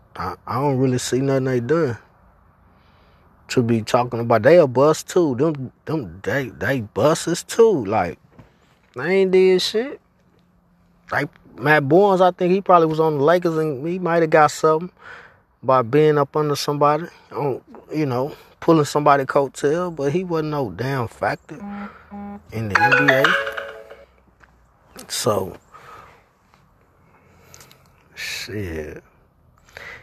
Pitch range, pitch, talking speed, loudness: 120-165 Hz, 145 Hz, 130 wpm, -19 LUFS